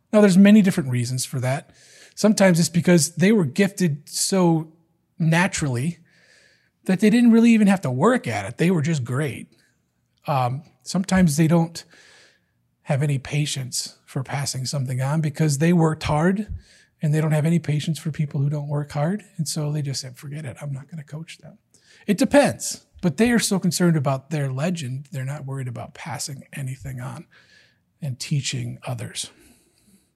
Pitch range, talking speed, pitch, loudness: 135-175 Hz, 175 wpm, 155 Hz, -21 LUFS